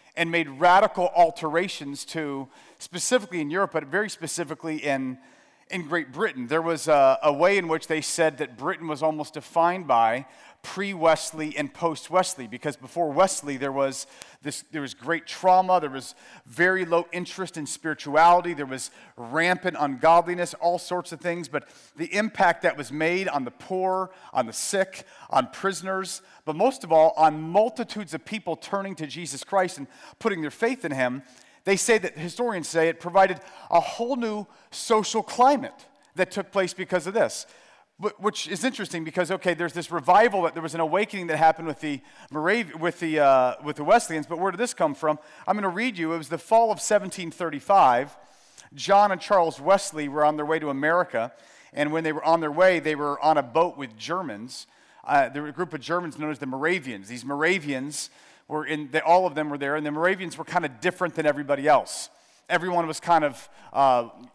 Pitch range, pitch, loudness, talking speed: 150-190 Hz, 165 Hz, -24 LUFS, 200 wpm